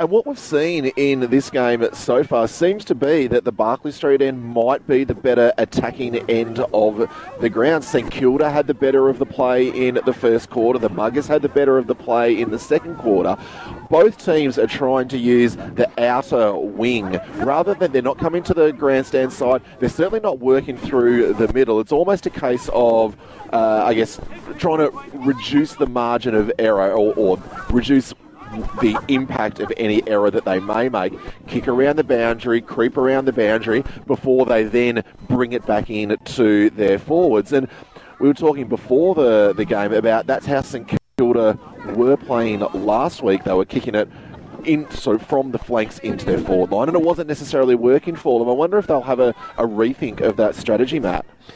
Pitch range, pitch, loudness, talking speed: 115-140 Hz, 125 Hz, -18 LUFS, 195 wpm